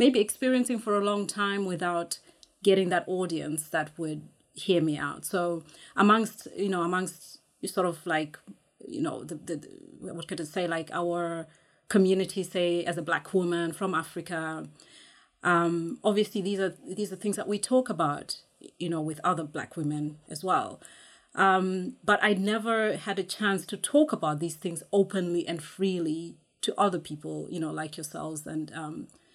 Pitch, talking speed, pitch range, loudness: 180 Hz, 170 wpm, 165-200 Hz, -29 LUFS